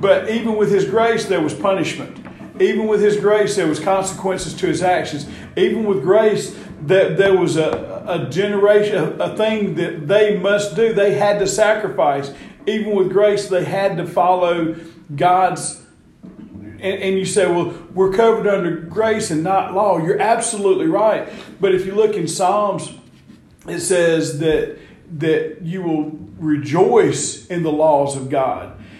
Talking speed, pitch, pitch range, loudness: 155 wpm, 190 Hz, 170-205 Hz, -17 LUFS